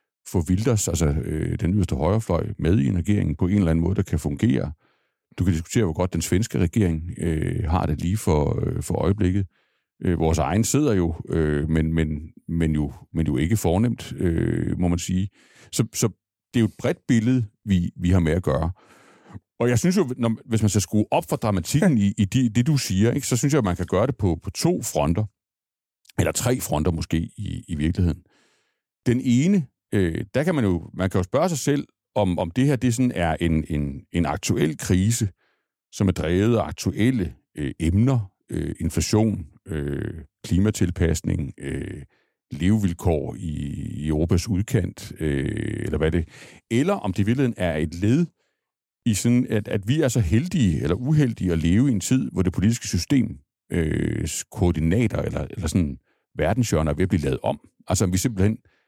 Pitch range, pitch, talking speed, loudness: 85-115 Hz, 95 Hz, 195 wpm, -23 LUFS